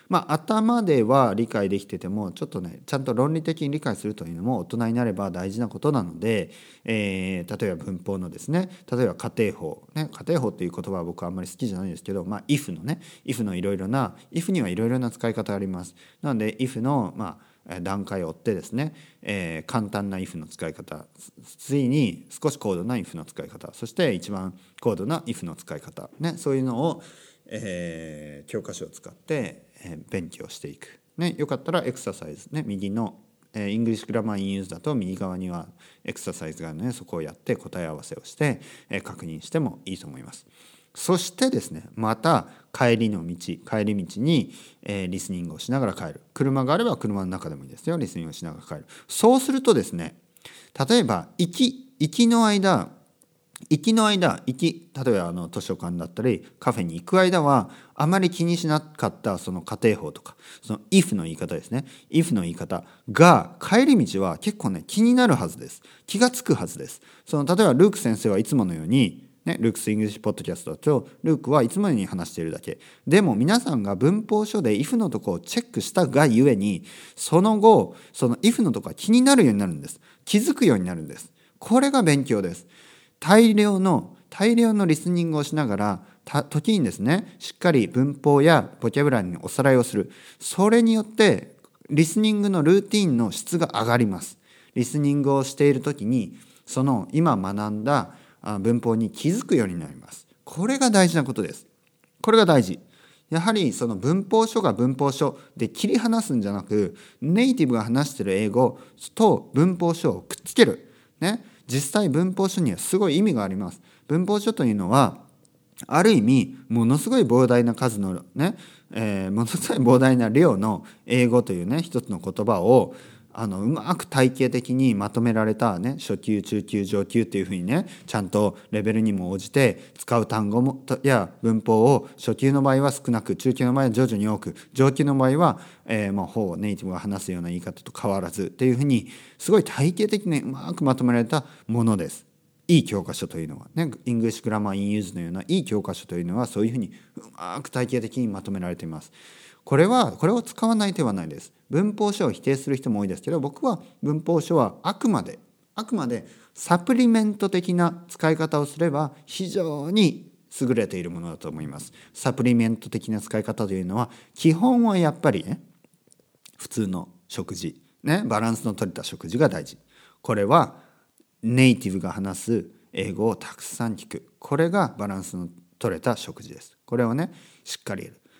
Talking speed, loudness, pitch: 385 characters per minute, -23 LUFS, 130 Hz